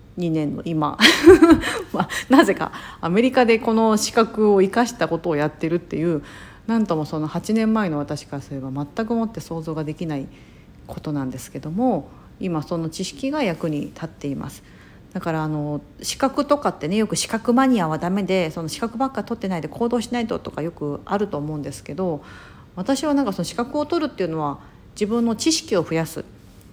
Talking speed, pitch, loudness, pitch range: 370 characters per minute, 175 Hz, -21 LUFS, 155-230 Hz